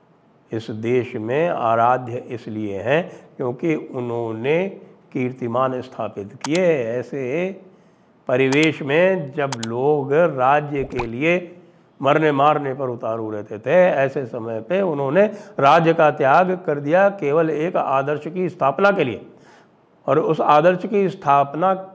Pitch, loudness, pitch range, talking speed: 145 Hz, -20 LUFS, 125-175 Hz, 125 wpm